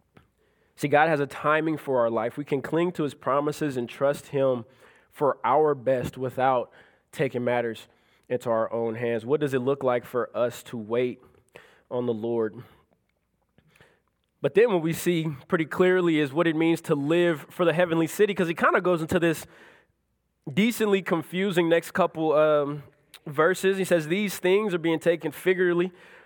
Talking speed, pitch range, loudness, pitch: 175 wpm, 130-175 Hz, -25 LUFS, 155 Hz